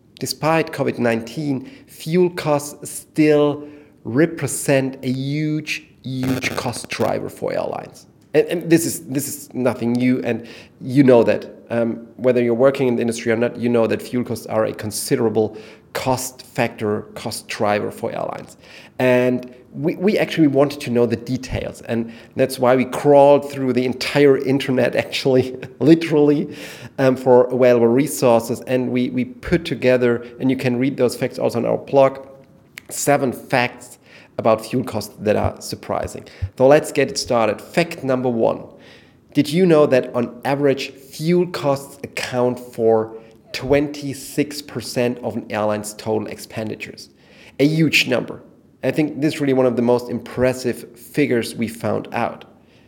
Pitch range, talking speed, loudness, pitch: 120-140 Hz, 155 wpm, -19 LUFS, 130 Hz